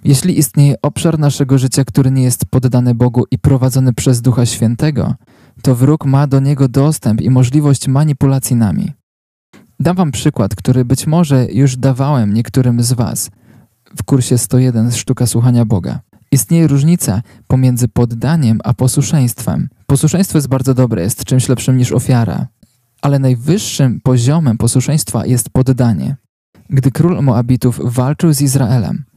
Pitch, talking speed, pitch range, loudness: 130 Hz, 140 wpm, 125-140 Hz, -13 LUFS